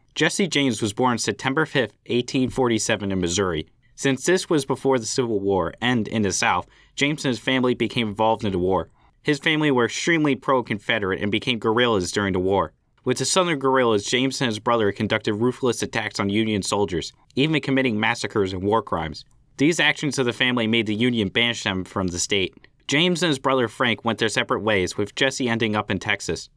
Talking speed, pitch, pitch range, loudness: 200 wpm, 120 Hz, 105-135 Hz, -22 LUFS